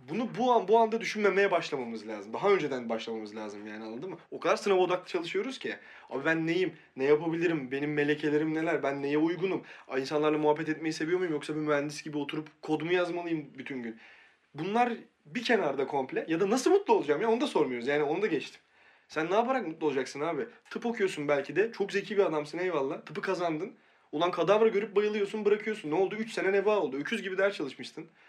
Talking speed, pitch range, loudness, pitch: 205 wpm, 150-210 Hz, -30 LUFS, 170 Hz